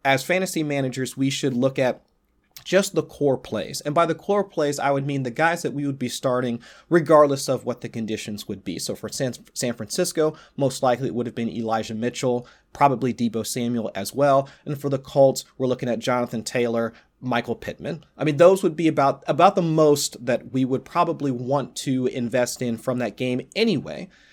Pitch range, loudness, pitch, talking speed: 120-150 Hz, -23 LUFS, 130 Hz, 200 wpm